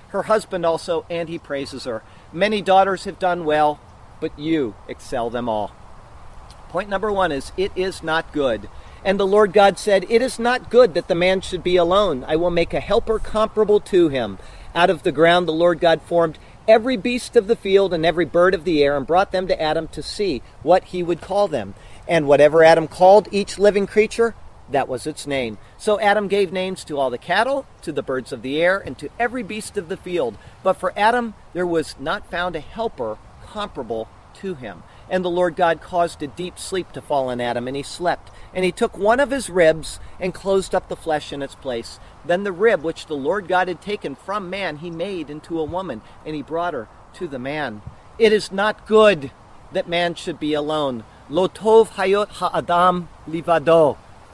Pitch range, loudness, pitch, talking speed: 150-195 Hz, -20 LUFS, 175 Hz, 210 wpm